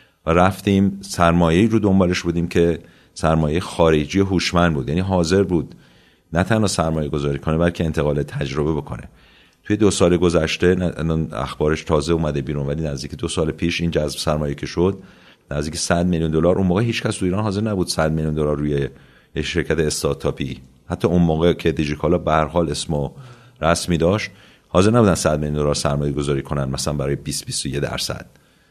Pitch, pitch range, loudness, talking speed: 85 Hz, 75-90 Hz, -20 LUFS, 175 wpm